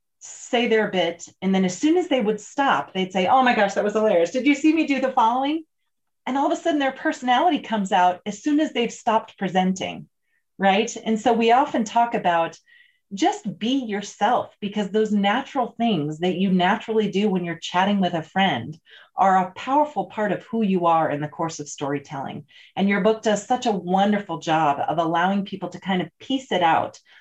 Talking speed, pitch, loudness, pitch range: 210 wpm, 210 Hz, -22 LUFS, 185-250 Hz